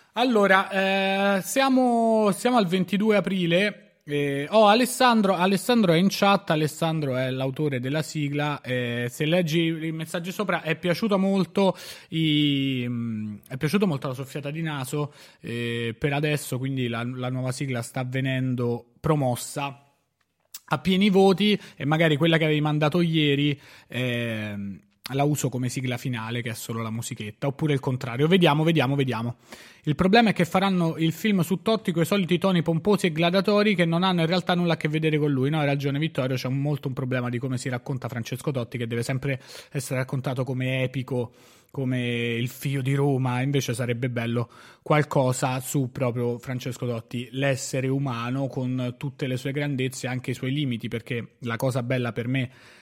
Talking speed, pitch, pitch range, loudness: 175 wpm, 140 Hz, 125-170 Hz, -25 LUFS